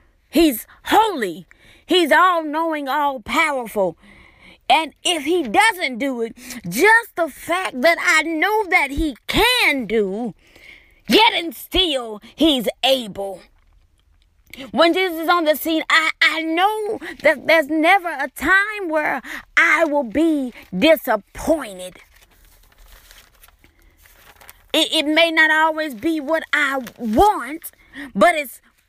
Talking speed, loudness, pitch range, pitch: 115 wpm, -17 LUFS, 240-335 Hz, 310 Hz